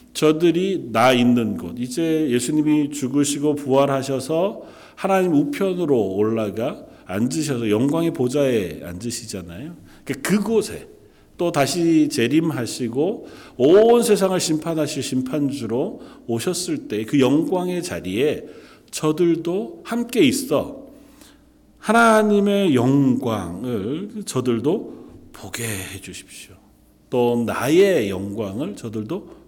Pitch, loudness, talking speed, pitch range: 145 Hz, -20 LUFS, 235 characters per minute, 115-185 Hz